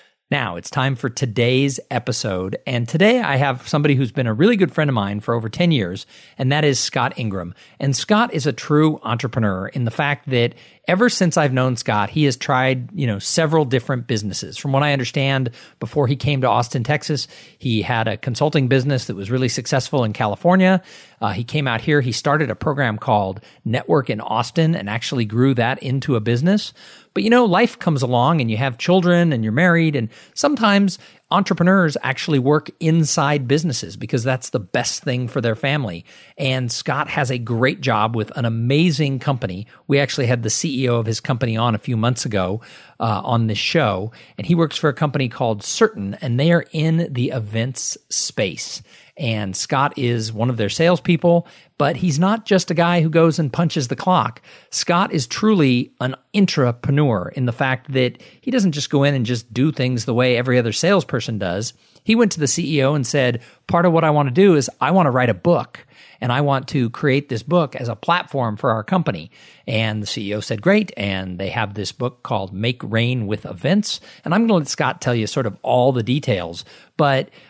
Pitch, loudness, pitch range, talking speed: 135 Hz, -19 LUFS, 120-155 Hz, 205 wpm